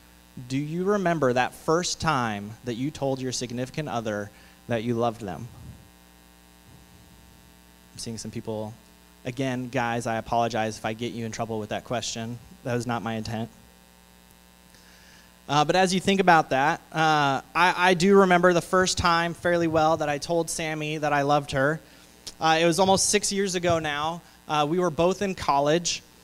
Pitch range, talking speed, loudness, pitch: 105-165 Hz, 175 wpm, -24 LUFS, 125 Hz